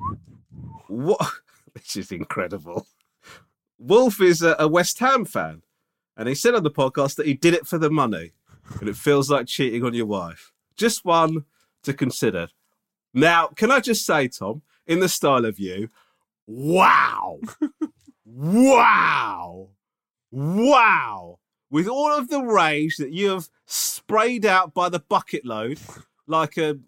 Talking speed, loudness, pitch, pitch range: 145 wpm, -20 LUFS, 160 Hz, 135-215 Hz